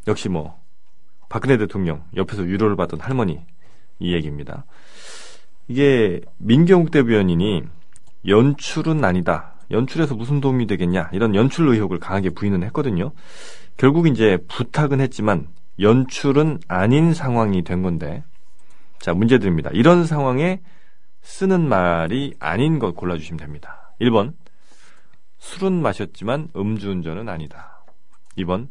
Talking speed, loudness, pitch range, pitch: 280 characters per minute, -19 LUFS, 90-140 Hz, 105 Hz